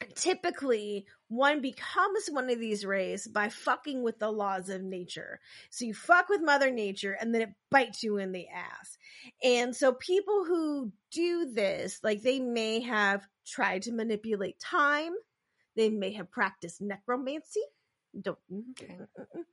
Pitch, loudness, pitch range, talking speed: 230 Hz, -31 LUFS, 200-285 Hz, 150 wpm